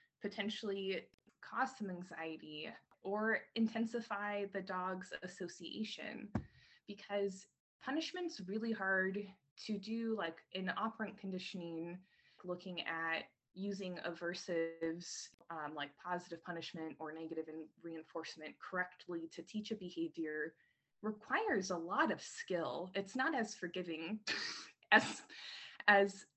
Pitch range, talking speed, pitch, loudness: 165-210 Hz, 105 wpm, 185 Hz, -41 LUFS